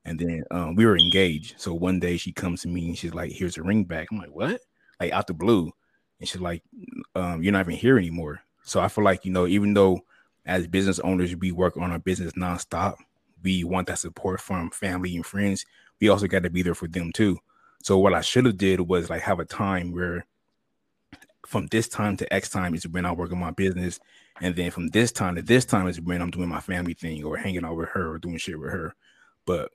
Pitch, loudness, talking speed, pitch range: 90 Hz, -25 LUFS, 245 wpm, 85-95 Hz